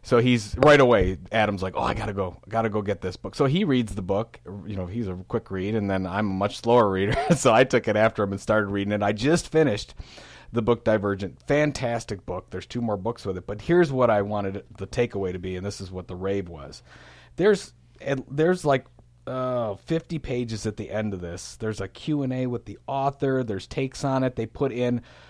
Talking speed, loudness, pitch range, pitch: 235 wpm, -25 LUFS, 100-125 Hz, 110 Hz